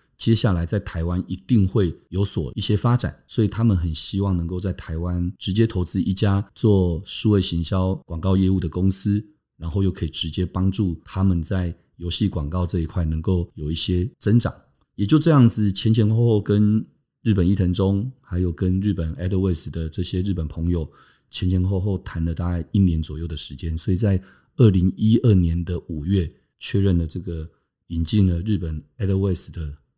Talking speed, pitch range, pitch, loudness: 300 characters per minute, 85-105 Hz, 95 Hz, -22 LUFS